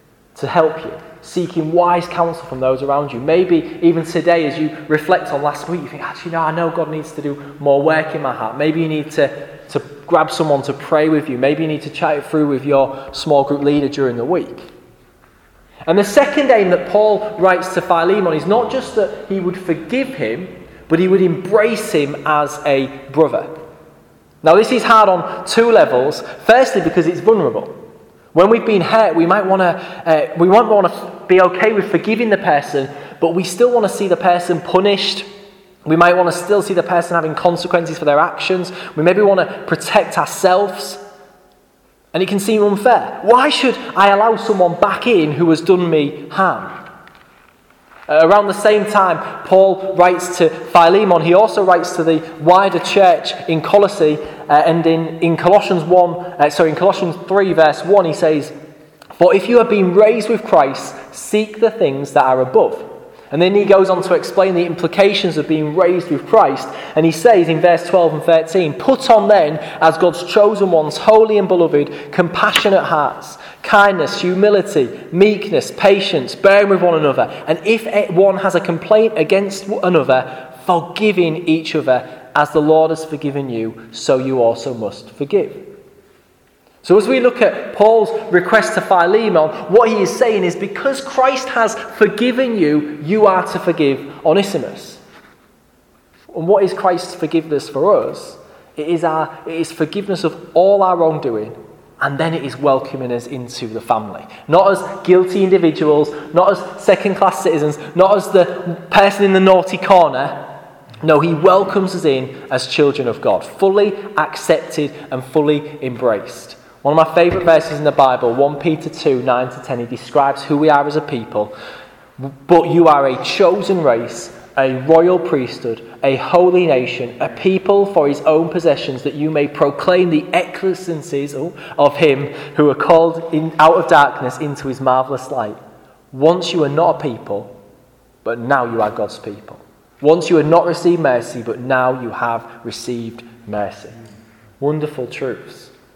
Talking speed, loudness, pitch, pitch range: 180 wpm, -14 LUFS, 170 Hz, 150-195 Hz